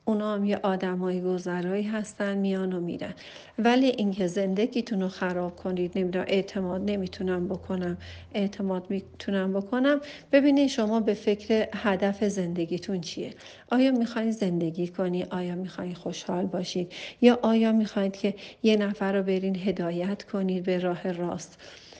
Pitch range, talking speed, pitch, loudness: 180-210 Hz, 135 wpm, 195 Hz, -27 LUFS